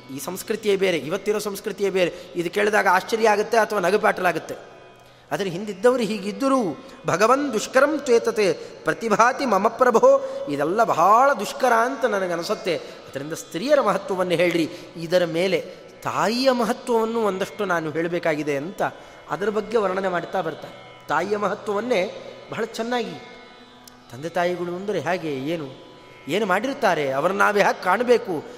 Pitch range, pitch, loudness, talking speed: 175-250 Hz, 210 Hz, -22 LUFS, 120 wpm